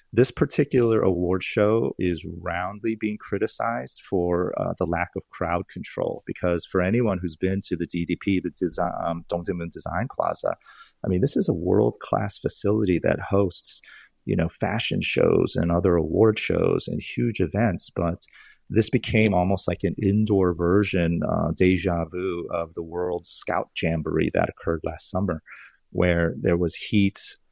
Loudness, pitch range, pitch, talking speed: -24 LUFS, 85-105 Hz, 90 Hz, 160 wpm